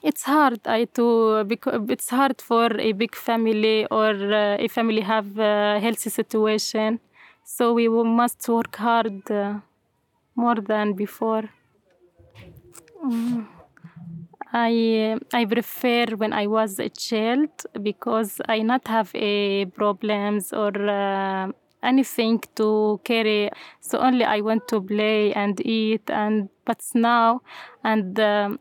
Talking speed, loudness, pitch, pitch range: 130 wpm, -22 LUFS, 220 Hz, 210-235 Hz